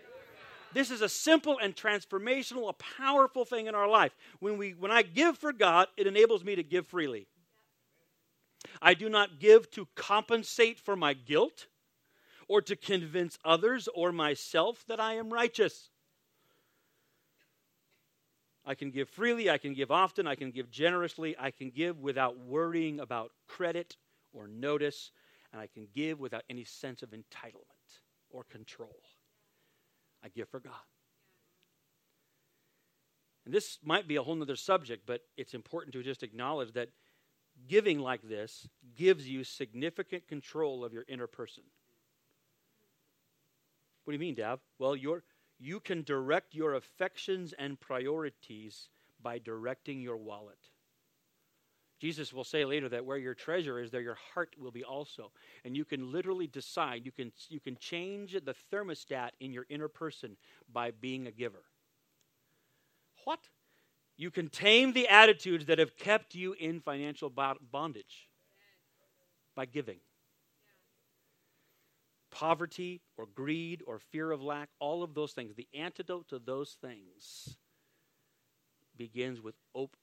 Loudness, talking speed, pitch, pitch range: -32 LUFS, 145 wpm, 155 Hz, 130-190 Hz